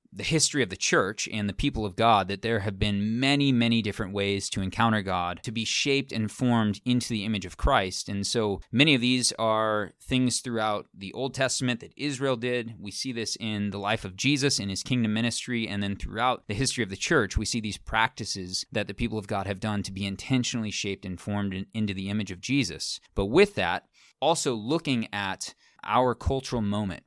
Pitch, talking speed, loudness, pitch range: 110 Hz, 215 wpm, -27 LUFS, 100-125 Hz